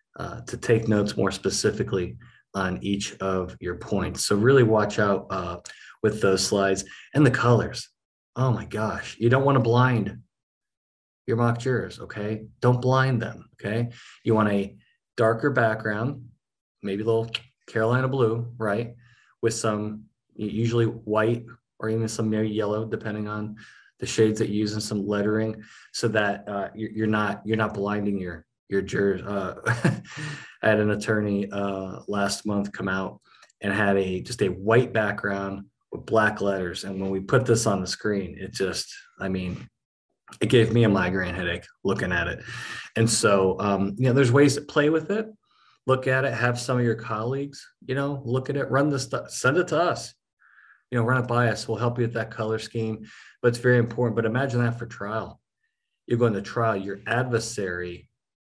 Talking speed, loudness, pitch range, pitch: 180 wpm, -25 LUFS, 100-120 Hz, 110 Hz